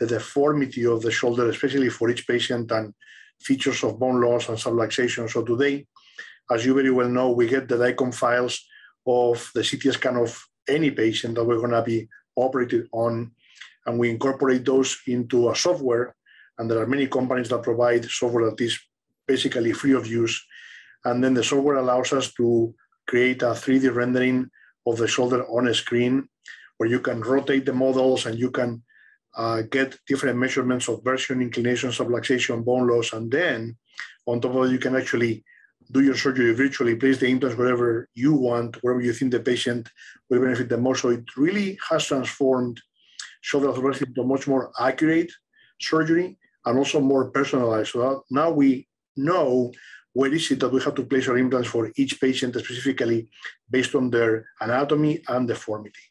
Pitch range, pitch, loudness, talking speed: 120-135 Hz, 125 Hz, -23 LUFS, 180 wpm